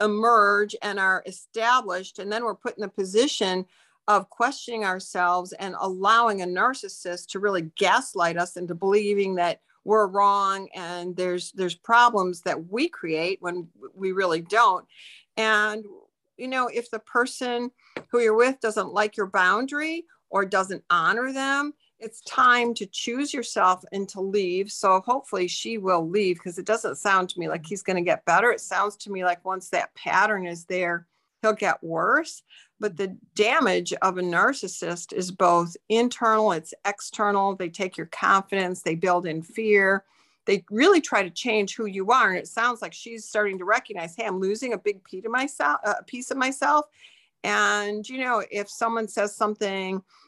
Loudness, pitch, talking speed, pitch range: -24 LUFS, 200 Hz, 170 wpm, 185-225 Hz